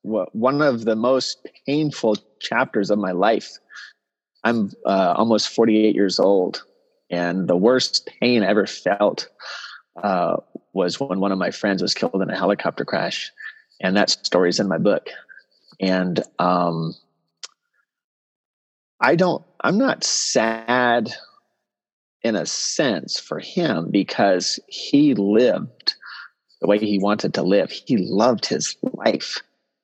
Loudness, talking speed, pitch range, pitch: -20 LUFS, 135 wpm, 95-120 Hz, 105 Hz